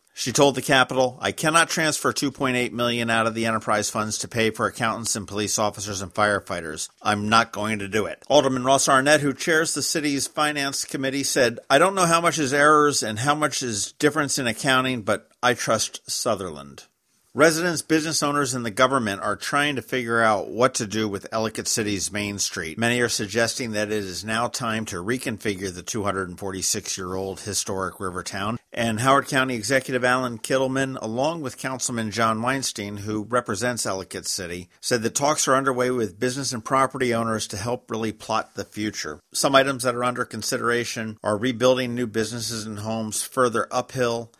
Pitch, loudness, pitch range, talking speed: 120 Hz, -23 LUFS, 105-135 Hz, 190 wpm